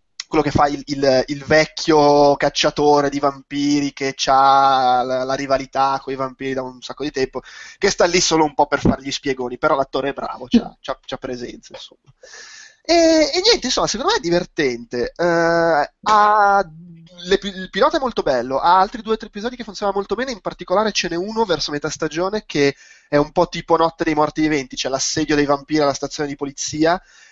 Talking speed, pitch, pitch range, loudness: 205 wpm, 155 Hz, 140-185 Hz, -18 LUFS